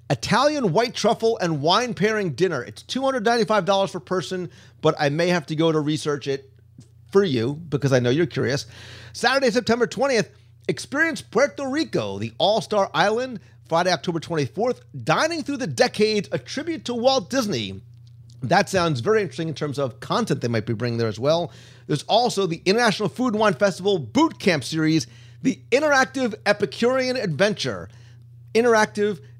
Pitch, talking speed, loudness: 180 Hz, 165 wpm, -22 LUFS